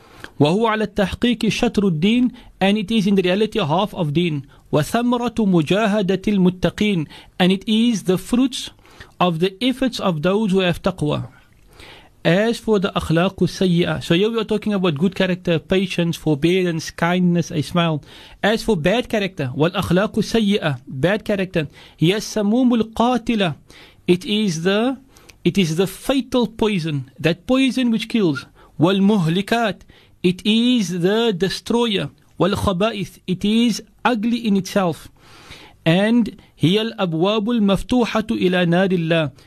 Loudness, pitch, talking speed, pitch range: -19 LUFS, 195 Hz, 135 wpm, 170-220 Hz